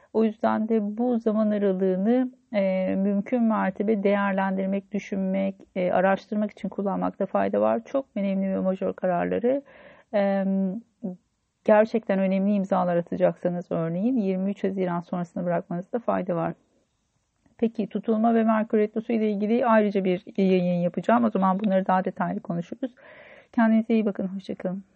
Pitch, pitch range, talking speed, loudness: 200 Hz, 190-225 Hz, 135 wpm, -25 LUFS